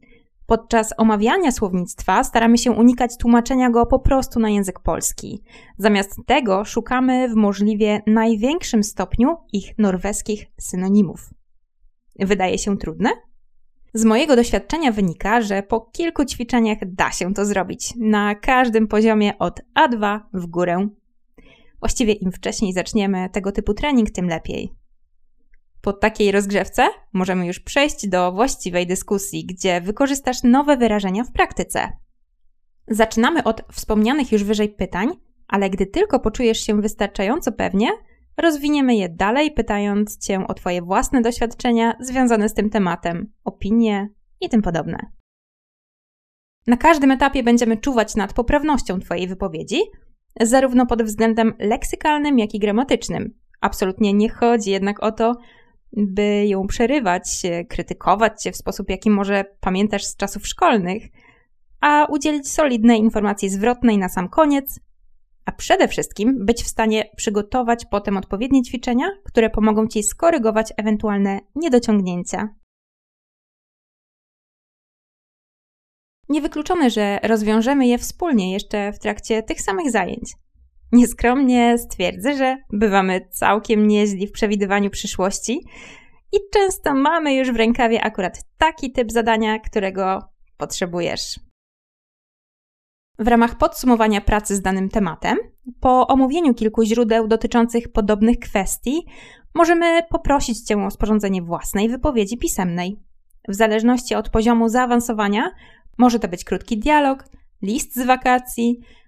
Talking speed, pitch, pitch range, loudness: 125 wpm, 220 Hz, 200-245 Hz, -19 LUFS